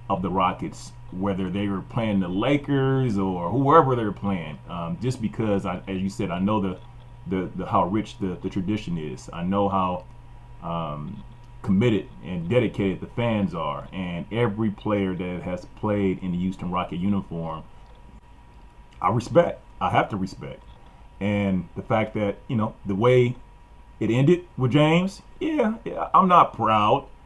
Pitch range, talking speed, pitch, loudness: 95-120 Hz, 165 wpm, 100 Hz, -24 LUFS